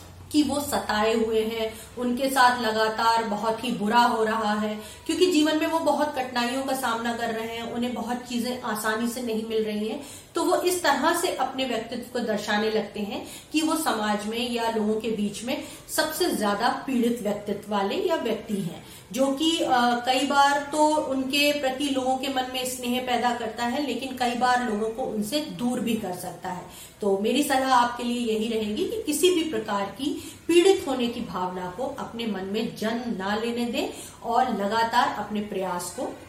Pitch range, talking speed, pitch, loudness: 220-270 Hz, 195 wpm, 240 Hz, -25 LUFS